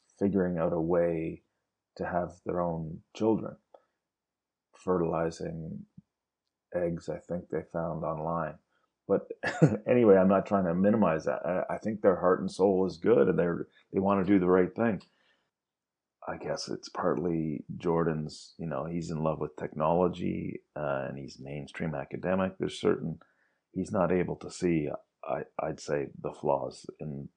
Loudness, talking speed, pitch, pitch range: -30 LUFS, 155 wpm, 85 Hz, 80-95 Hz